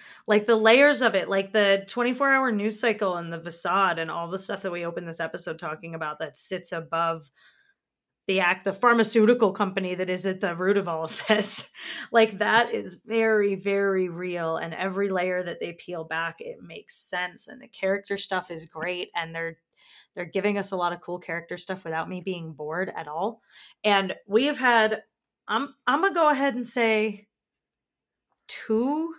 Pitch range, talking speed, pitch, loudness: 175-225 Hz, 190 wpm, 195 Hz, -25 LUFS